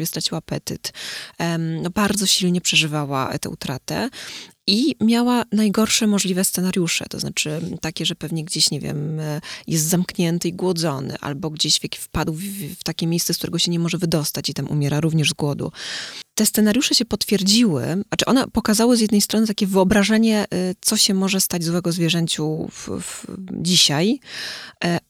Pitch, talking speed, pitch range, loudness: 175 Hz, 155 wpm, 160-205 Hz, -20 LUFS